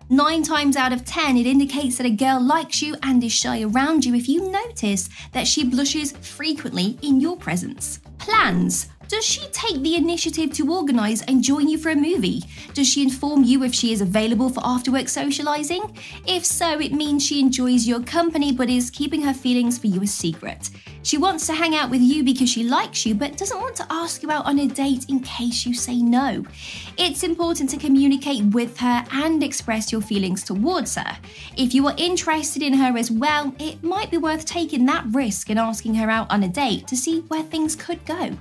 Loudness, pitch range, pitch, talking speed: -21 LUFS, 240-310 Hz, 270 Hz, 210 wpm